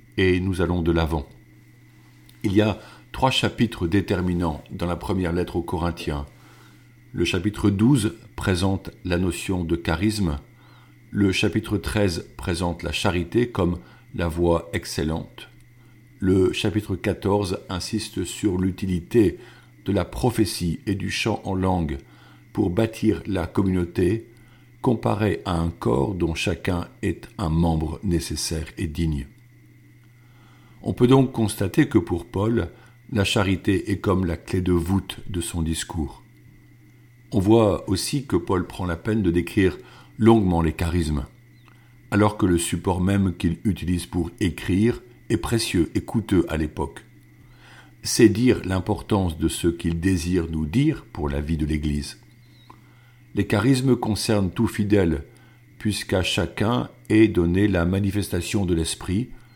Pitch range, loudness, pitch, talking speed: 85-110 Hz, -23 LUFS, 95 Hz, 140 wpm